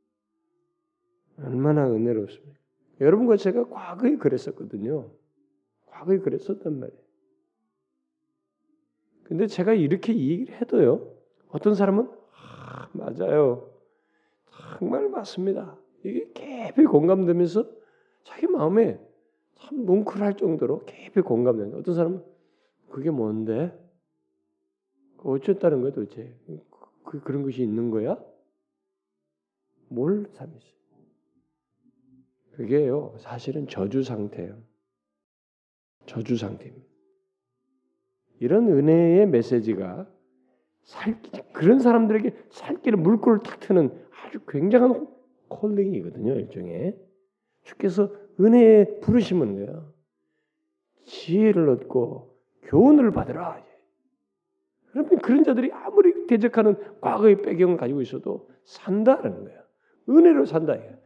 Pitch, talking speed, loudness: 195 Hz, 240 characters per minute, -22 LUFS